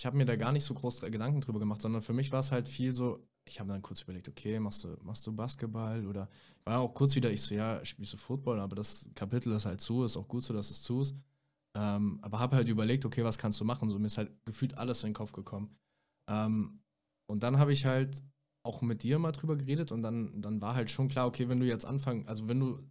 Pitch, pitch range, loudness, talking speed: 115 Hz, 105-130 Hz, -34 LUFS, 265 wpm